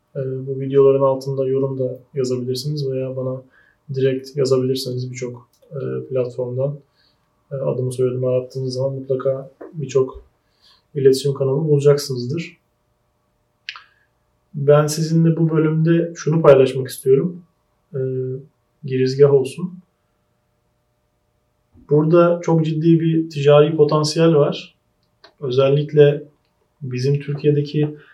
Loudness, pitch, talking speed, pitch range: -18 LUFS, 135 Hz, 85 wpm, 130-150 Hz